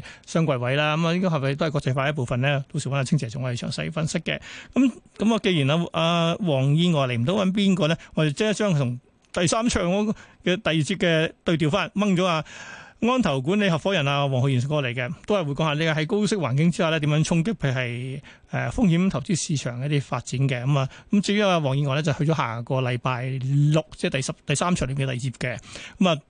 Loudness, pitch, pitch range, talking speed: -23 LUFS, 155 Hz, 135-180 Hz, 350 characters per minute